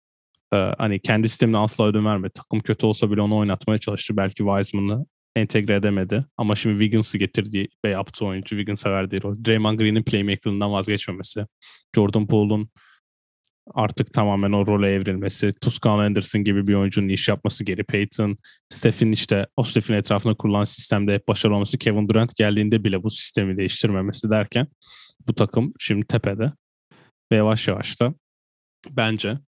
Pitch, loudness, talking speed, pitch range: 105 Hz, -22 LUFS, 150 wpm, 100-110 Hz